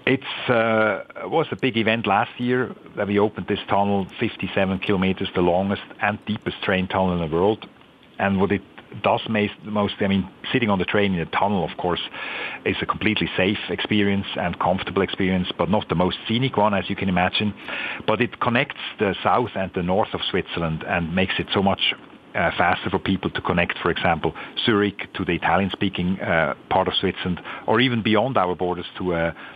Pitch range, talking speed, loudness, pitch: 95-105 Hz, 200 wpm, -22 LUFS, 100 Hz